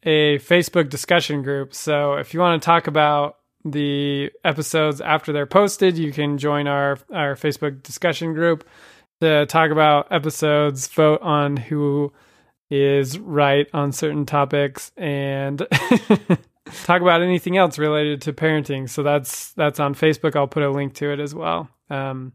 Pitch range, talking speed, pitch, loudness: 145-160 Hz, 155 wpm, 150 Hz, -20 LUFS